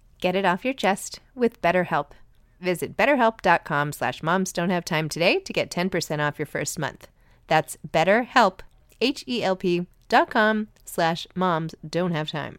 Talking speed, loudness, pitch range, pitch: 145 wpm, -24 LUFS, 155-205 Hz, 175 Hz